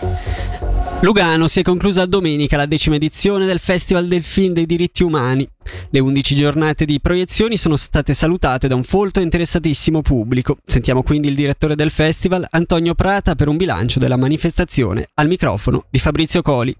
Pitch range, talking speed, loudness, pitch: 135-175 Hz, 170 wpm, -16 LUFS, 155 Hz